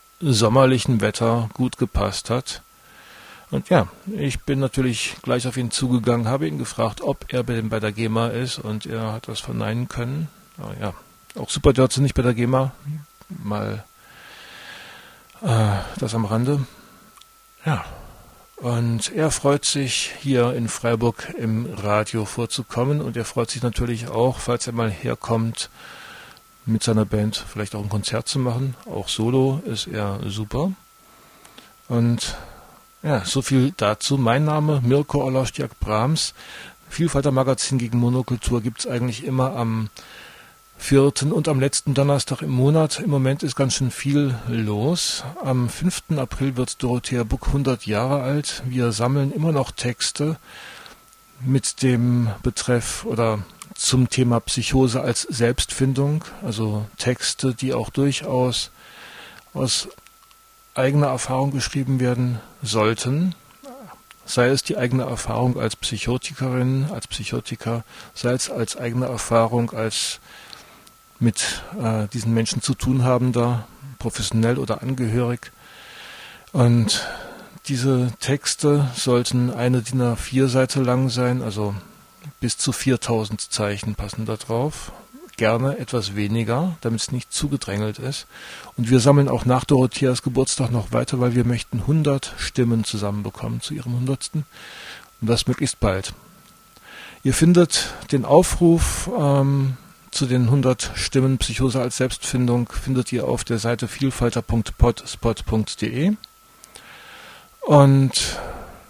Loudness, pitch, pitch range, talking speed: -22 LUFS, 125 Hz, 115-135 Hz, 130 wpm